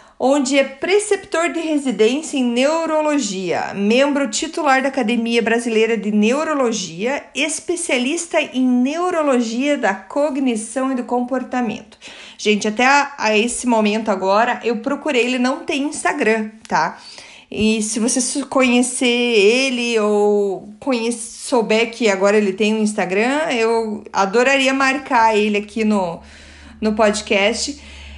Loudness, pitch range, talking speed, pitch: -17 LUFS, 215-275 Hz, 125 wpm, 240 Hz